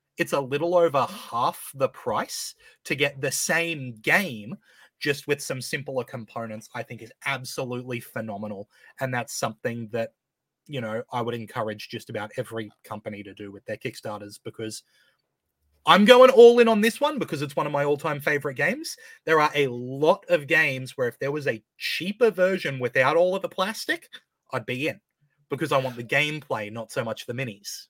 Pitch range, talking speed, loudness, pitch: 115-170 Hz, 185 wpm, -24 LUFS, 140 Hz